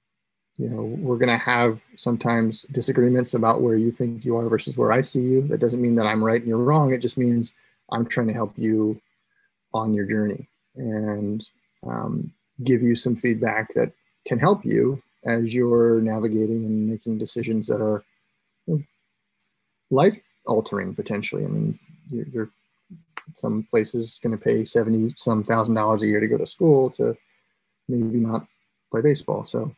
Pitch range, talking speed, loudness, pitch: 110-125 Hz, 170 wpm, -23 LUFS, 115 Hz